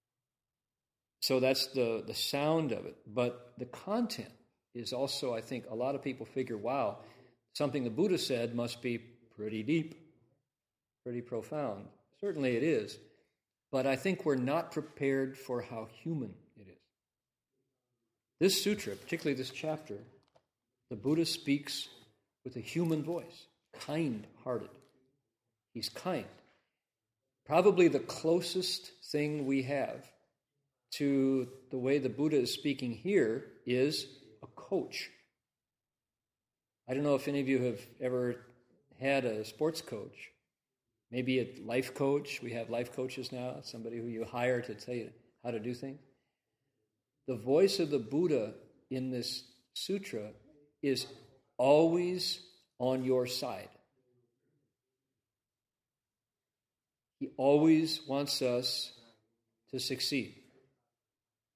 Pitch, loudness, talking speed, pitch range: 130 Hz, -34 LUFS, 125 wpm, 120-145 Hz